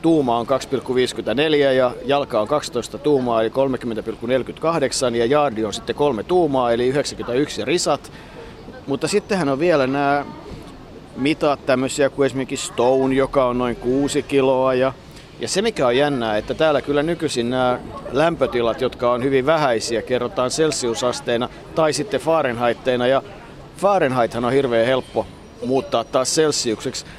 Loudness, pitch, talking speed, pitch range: -20 LUFS, 130 Hz, 140 wpm, 120-145 Hz